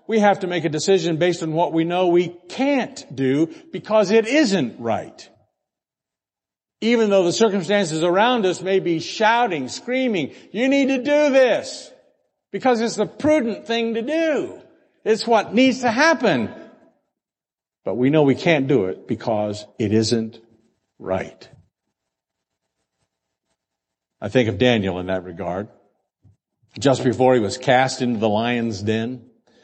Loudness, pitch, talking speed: -20 LUFS, 175 Hz, 145 wpm